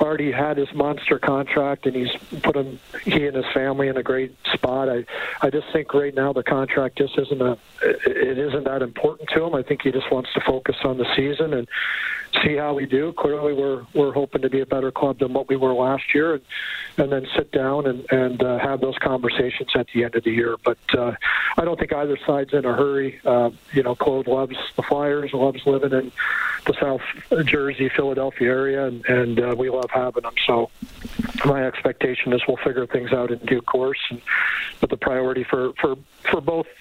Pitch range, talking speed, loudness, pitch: 130-145 Hz, 215 wpm, -22 LUFS, 135 Hz